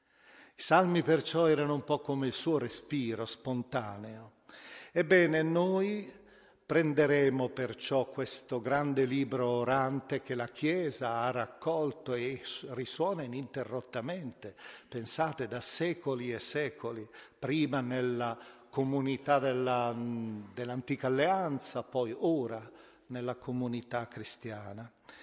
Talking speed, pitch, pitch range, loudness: 100 wpm, 130 Hz, 120-145 Hz, -32 LUFS